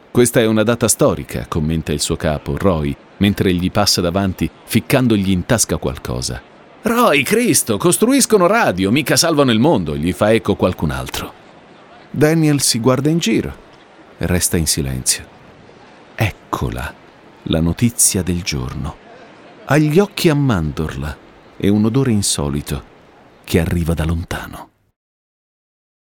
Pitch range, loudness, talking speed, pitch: 80-120 Hz, -16 LUFS, 135 wpm, 95 Hz